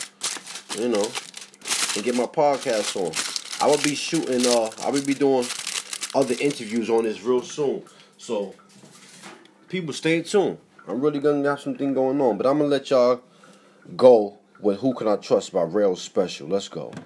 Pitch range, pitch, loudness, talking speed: 120-145 Hz, 135 Hz, -23 LUFS, 170 wpm